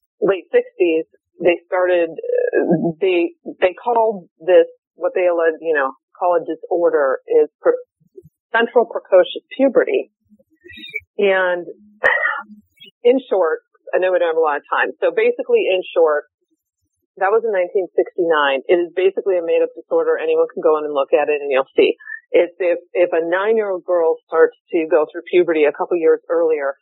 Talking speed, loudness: 170 wpm, -18 LUFS